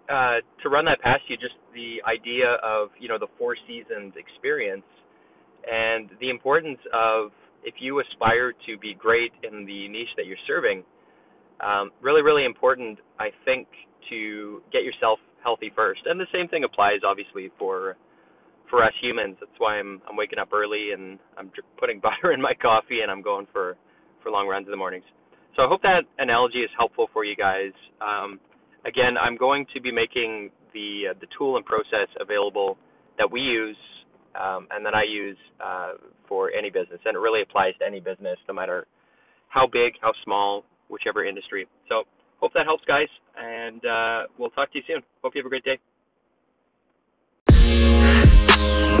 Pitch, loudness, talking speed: 130 Hz, -23 LUFS, 180 wpm